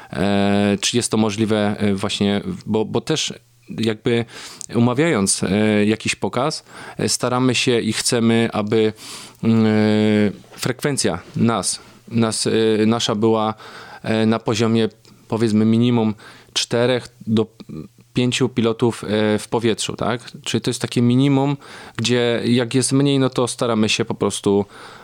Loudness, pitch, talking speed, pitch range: -19 LUFS, 115 Hz, 115 wpm, 110-120 Hz